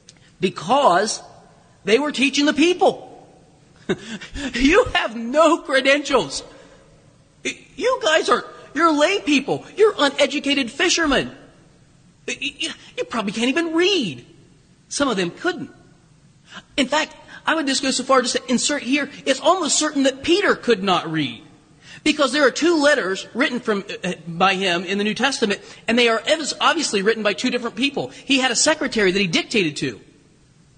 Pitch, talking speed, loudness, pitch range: 260 Hz, 150 wpm, -19 LUFS, 190-300 Hz